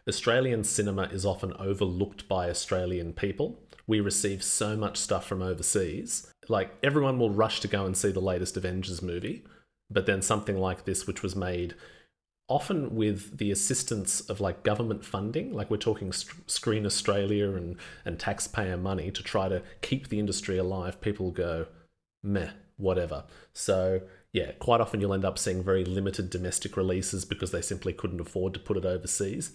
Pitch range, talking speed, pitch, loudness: 95-105 Hz, 170 wpm, 100 Hz, -30 LUFS